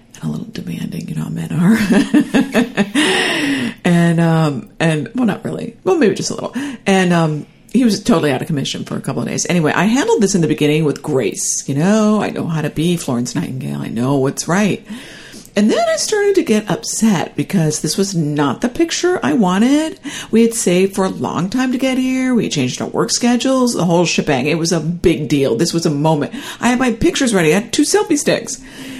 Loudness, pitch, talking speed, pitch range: -16 LUFS, 205 Hz, 220 wpm, 160-255 Hz